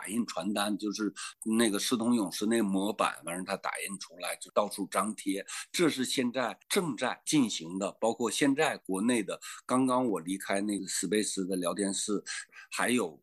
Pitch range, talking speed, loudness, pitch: 95-120 Hz, 270 characters per minute, -31 LUFS, 105 Hz